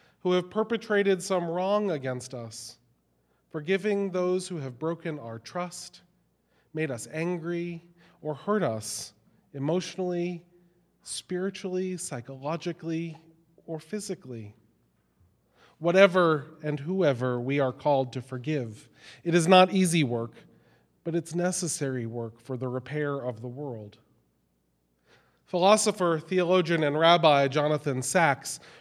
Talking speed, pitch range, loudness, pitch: 110 wpm, 130-180 Hz, -27 LUFS, 160 Hz